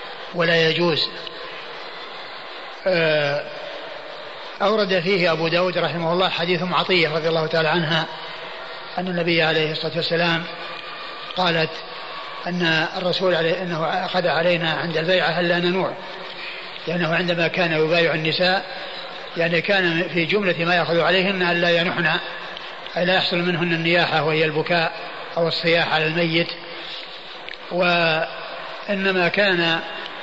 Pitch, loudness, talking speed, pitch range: 170 Hz, -20 LUFS, 120 wpm, 165-180 Hz